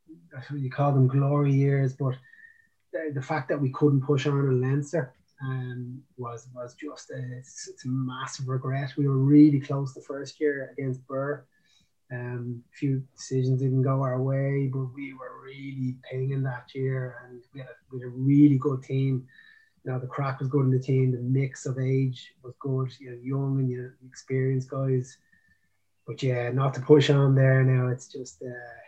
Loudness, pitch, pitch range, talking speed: -26 LUFS, 135 Hz, 130-140 Hz, 190 wpm